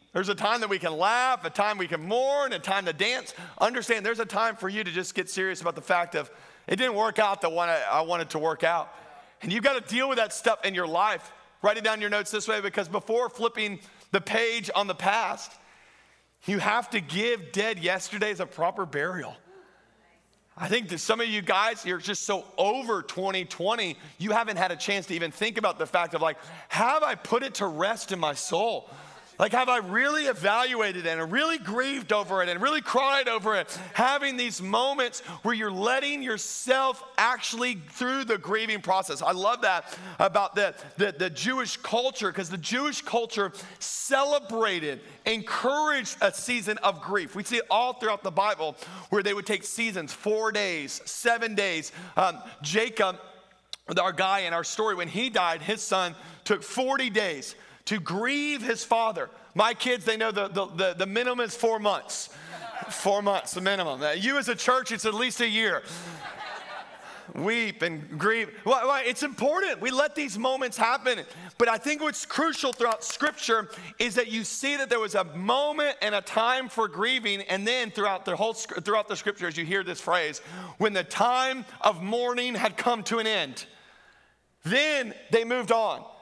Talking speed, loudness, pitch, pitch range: 190 wpm, -27 LUFS, 215 Hz, 190-245 Hz